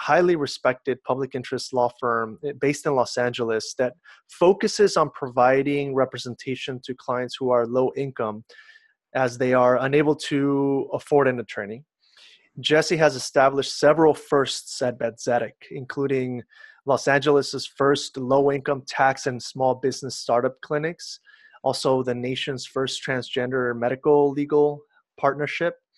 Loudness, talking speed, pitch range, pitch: -23 LUFS, 130 wpm, 125-145 Hz, 135 Hz